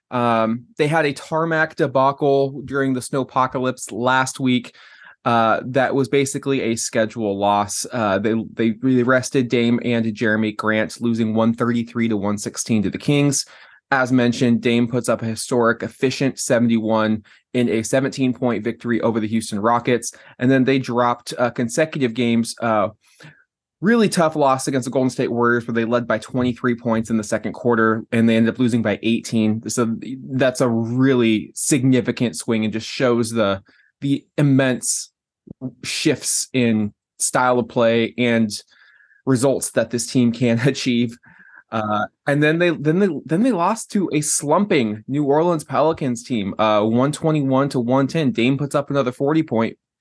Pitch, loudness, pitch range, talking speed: 120 Hz, -19 LUFS, 115-135 Hz, 160 wpm